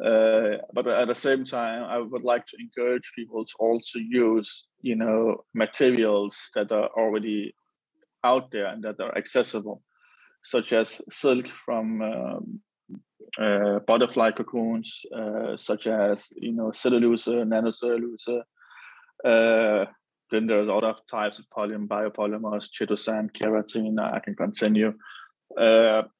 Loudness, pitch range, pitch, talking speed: -25 LUFS, 110-120 Hz, 115 Hz, 130 wpm